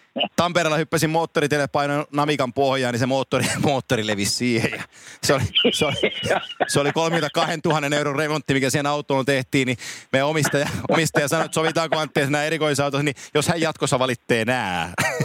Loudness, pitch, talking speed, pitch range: -21 LUFS, 145 Hz, 155 wpm, 135-155 Hz